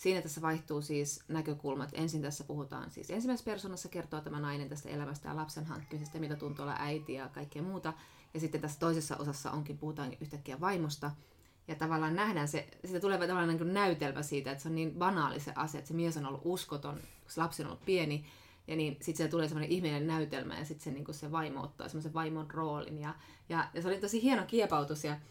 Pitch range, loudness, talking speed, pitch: 145-165 Hz, -37 LUFS, 210 wpm, 155 Hz